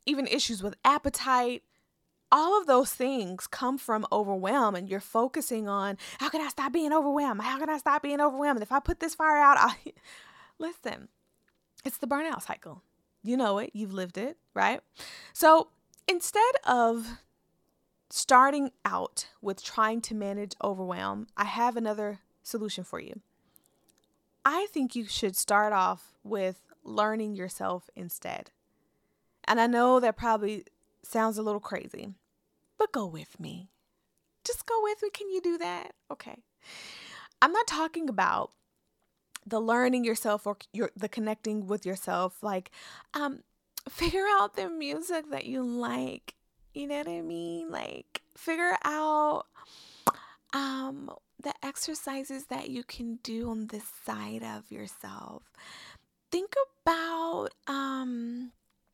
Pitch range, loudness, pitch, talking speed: 210-285 Hz, -29 LUFS, 245 Hz, 145 wpm